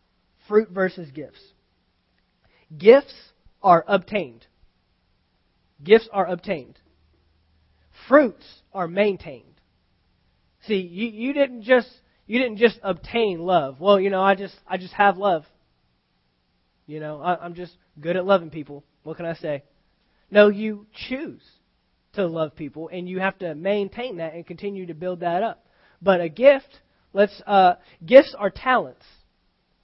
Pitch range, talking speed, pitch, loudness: 150-205 Hz, 140 wpm, 180 Hz, -21 LUFS